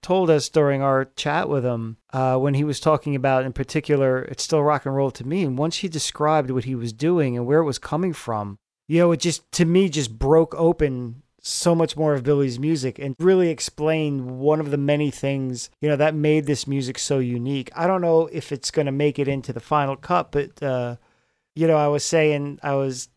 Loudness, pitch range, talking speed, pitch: -22 LUFS, 130-155 Hz, 230 wpm, 145 Hz